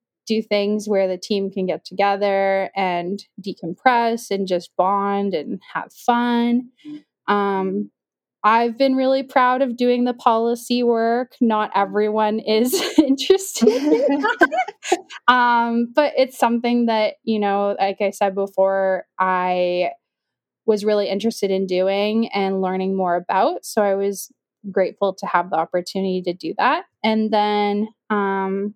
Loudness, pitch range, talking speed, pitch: -20 LUFS, 195-240 Hz, 135 wpm, 210 Hz